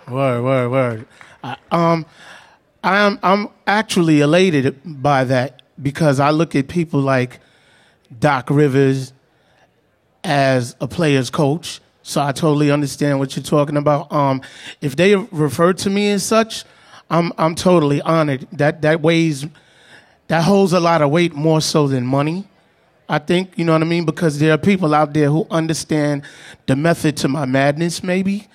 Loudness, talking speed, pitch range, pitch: -17 LUFS, 160 wpm, 140-170 Hz, 155 Hz